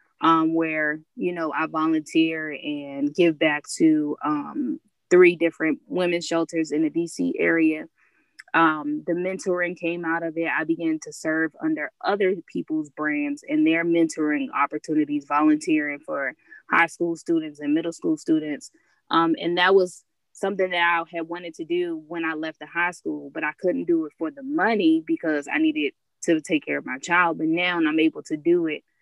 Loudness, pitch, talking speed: -23 LUFS, 170 Hz, 180 wpm